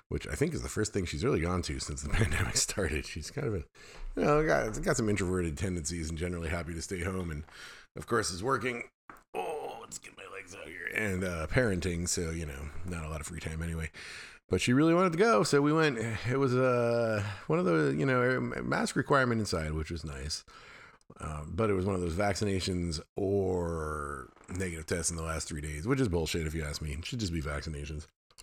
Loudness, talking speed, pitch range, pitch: -31 LUFS, 230 wpm, 80-115 Hz, 90 Hz